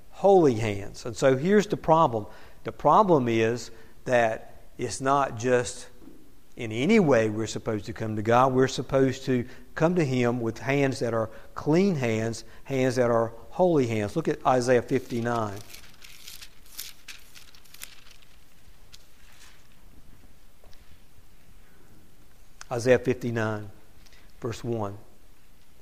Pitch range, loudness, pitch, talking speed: 110-135 Hz, -25 LUFS, 120 Hz, 110 wpm